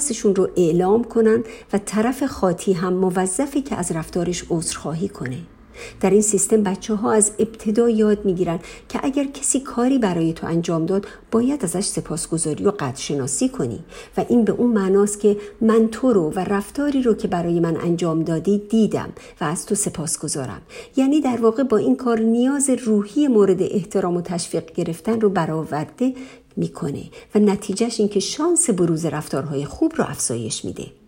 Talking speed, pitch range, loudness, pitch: 170 wpm, 175-230 Hz, -20 LUFS, 205 Hz